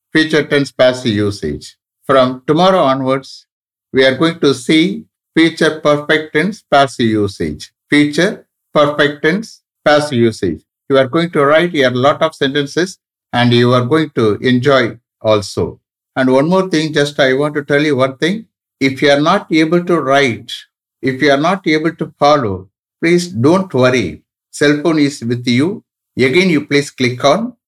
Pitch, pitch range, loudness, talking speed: 145 Hz, 130-160 Hz, -13 LUFS, 165 wpm